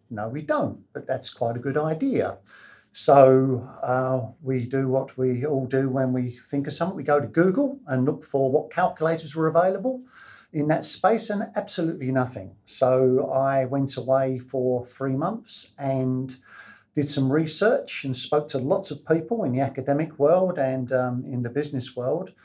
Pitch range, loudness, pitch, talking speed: 130-160 Hz, -24 LUFS, 135 Hz, 175 wpm